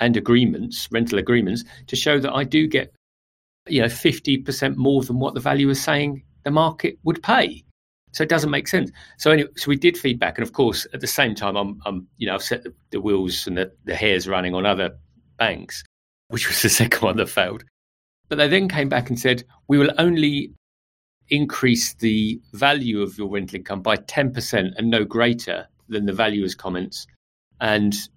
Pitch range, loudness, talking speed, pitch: 95-140 Hz, -21 LUFS, 200 wpm, 115 Hz